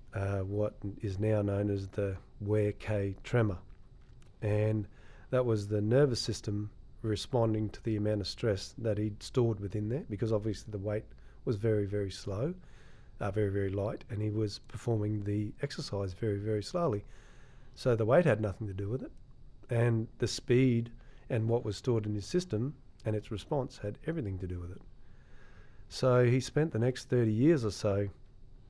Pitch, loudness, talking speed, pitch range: 110 Hz, -33 LUFS, 180 wpm, 100-125 Hz